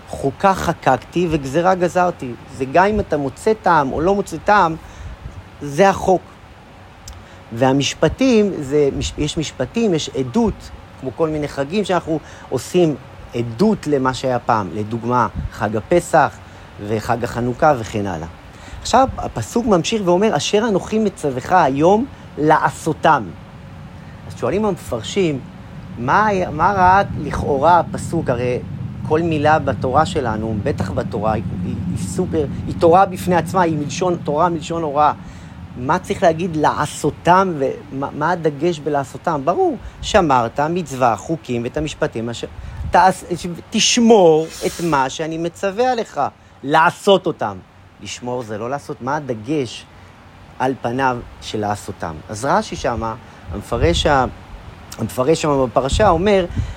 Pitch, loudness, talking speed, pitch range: 140 Hz, -18 LUFS, 125 wpm, 110-175 Hz